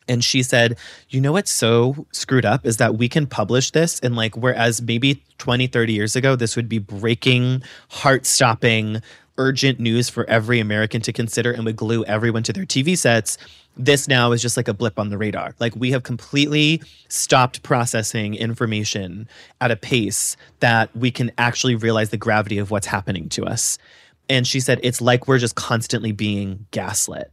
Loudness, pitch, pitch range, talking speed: -19 LUFS, 120 Hz, 110-130 Hz, 190 wpm